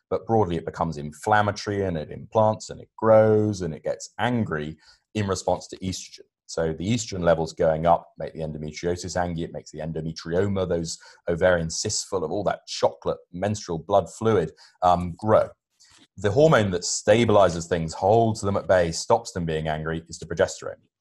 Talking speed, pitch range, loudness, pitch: 175 wpm, 80-105 Hz, -24 LUFS, 90 Hz